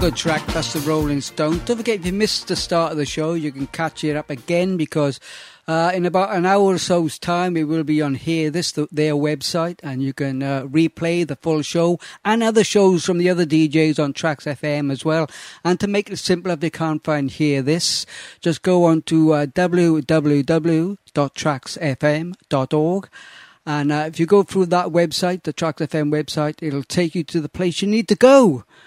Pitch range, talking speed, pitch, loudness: 150-180 Hz, 215 wpm, 160 Hz, -19 LUFS